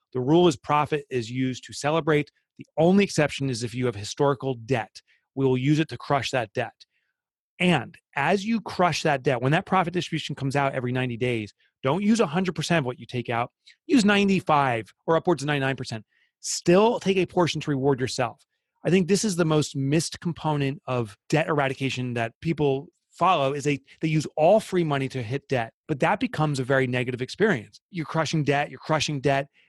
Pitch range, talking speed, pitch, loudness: 130-170 Hz, 200 wpm, 145 Hz, -25 LUFS